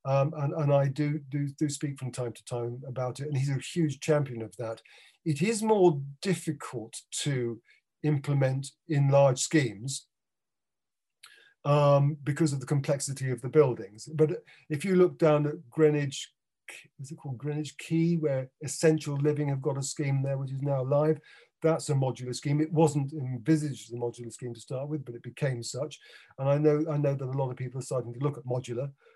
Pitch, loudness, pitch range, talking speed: 140 Hz, -29 LUFS, 130-155 Hz, 200 wpm